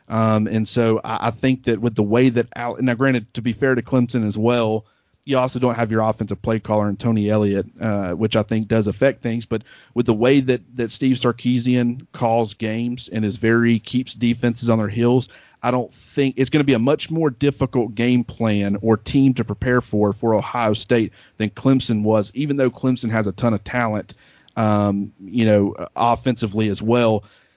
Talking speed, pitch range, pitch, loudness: 205 wpm, 110-125 Hz, 115 Hz, -20 LUFS